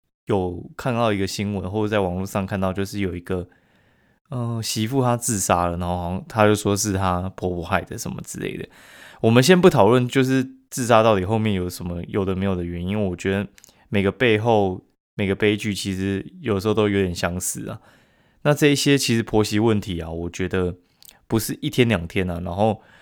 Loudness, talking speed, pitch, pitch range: -22 LUFS, 310 characters per minute, 100 Hz, 95-115 Hz